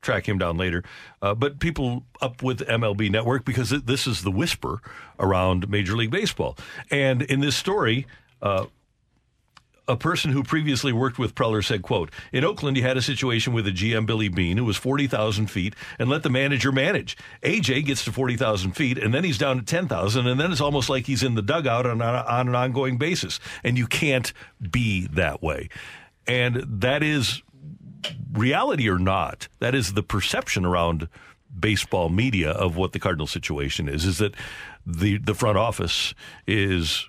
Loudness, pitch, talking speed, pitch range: -24 LUFS, 120 Hz, 185 wpm, 100-135 Hz